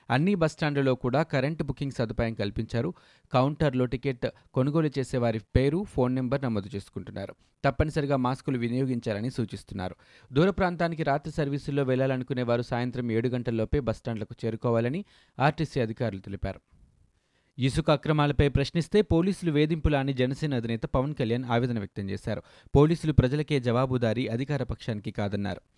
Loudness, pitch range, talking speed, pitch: -28 LUFS, 115-145 Hz, 125 wpm, 130 Hz